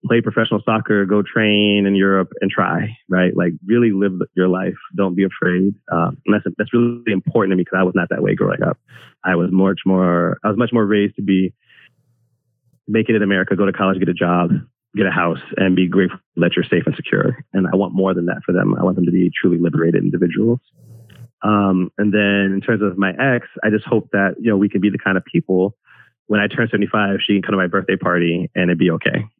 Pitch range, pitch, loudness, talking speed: 95-110 Hz, 100 Hz, -17 LUFS, 240 wpm